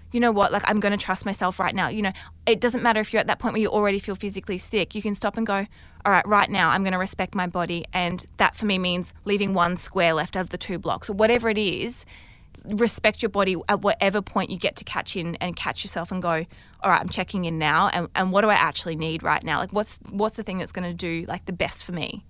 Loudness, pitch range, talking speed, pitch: -24 LUFS, 180-210 Hz, 285 wpm, 195 Hz